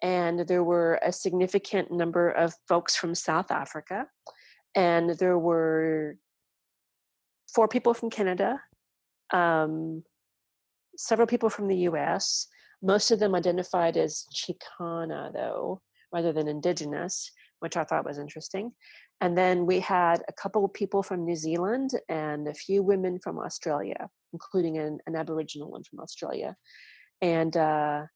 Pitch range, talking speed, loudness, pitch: 160-195 Hz, 140 wpm, -28 LUFS, 175 Hz